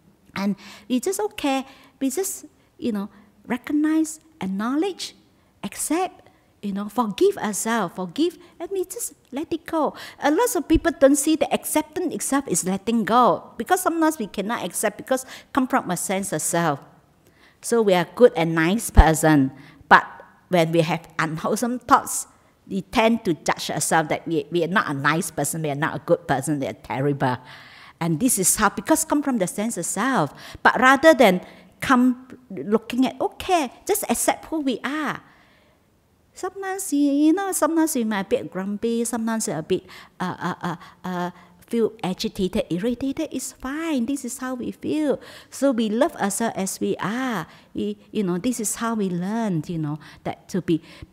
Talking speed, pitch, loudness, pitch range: 175 wpm, 225 Hz, -22 LUFS, 180-280 Hz